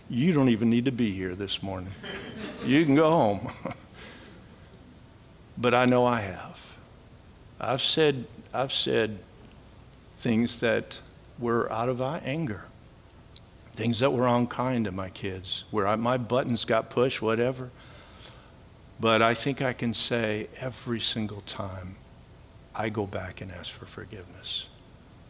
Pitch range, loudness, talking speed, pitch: 100-125 Hz, -27 LUFS, 140 wpm, 115 Hz